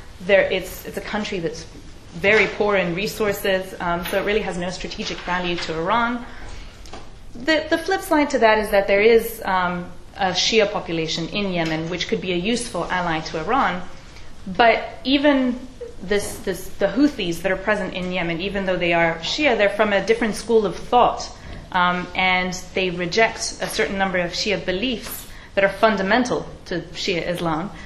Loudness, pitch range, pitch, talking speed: -21 LUFS, 180-220 Hz, 195 Hz, 180 wpm